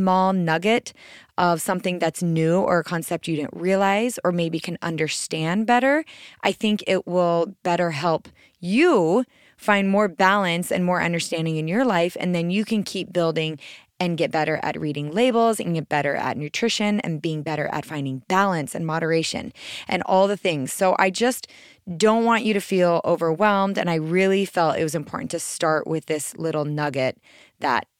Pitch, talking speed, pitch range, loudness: 175 Hz, 180 wpm, 160-200 Hz, -22 LUFS